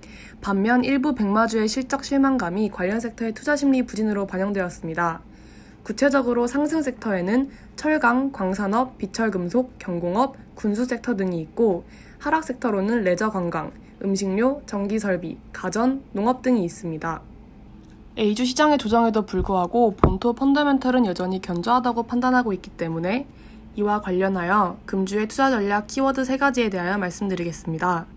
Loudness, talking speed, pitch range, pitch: -23 LUFS, 340 characters per minute, 185-250 Hz, 215 Hz